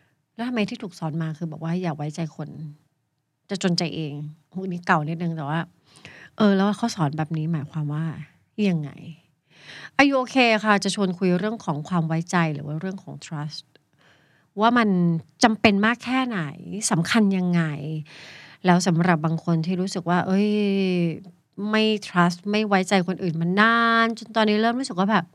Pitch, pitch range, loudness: 175 Hz, 155-205 Hz, -23 LUFS